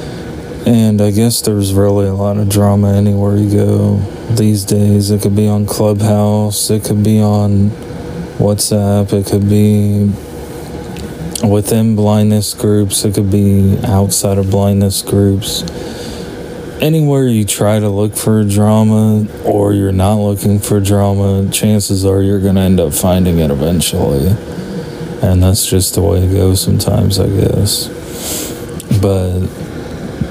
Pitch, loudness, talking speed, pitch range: 100 Hz, -12 LUFS, 140 wpm, 100-105 Hz